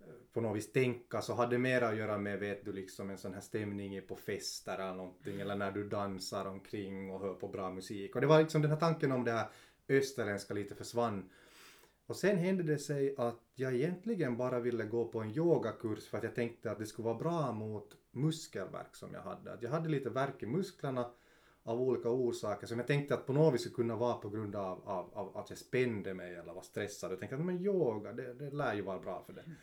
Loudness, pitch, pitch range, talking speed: -37 LUFS, 120 Hz, 100-135 Hz, 235 wpm